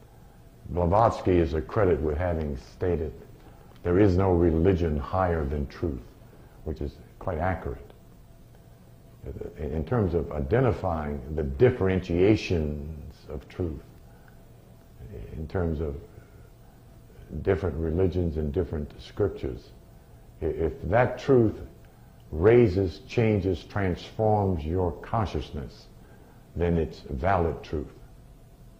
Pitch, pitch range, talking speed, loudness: 85 Hz, 75-95 Hz, 95 wpm, -27 LUFS